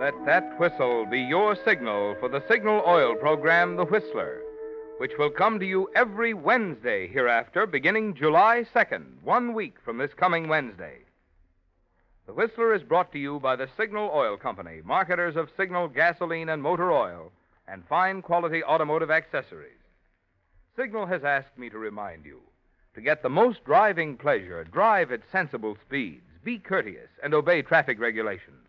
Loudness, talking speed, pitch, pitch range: -25 LUFS, 160 wpm, 170 Hz, 140-215 Hz